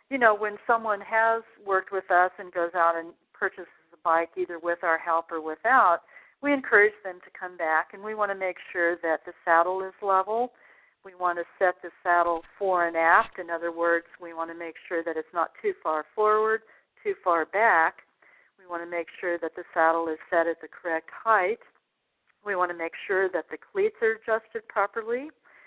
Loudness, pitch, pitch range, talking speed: -26 LUFS, 180 Hz, 170-215 Hz, 210 wpm